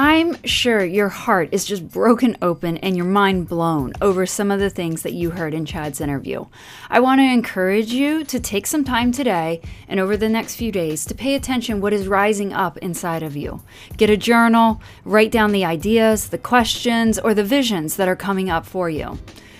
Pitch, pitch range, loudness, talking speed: 200 Hz, 170-230 Hz, -19 LUFS, 205 wpm